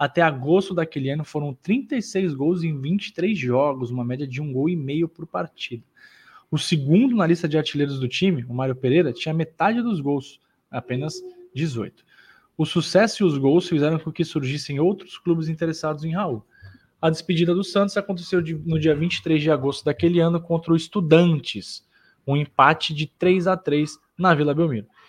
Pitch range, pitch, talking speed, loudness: 145-175 Hz, 160 Hz, 175 wpm, -22 LUFS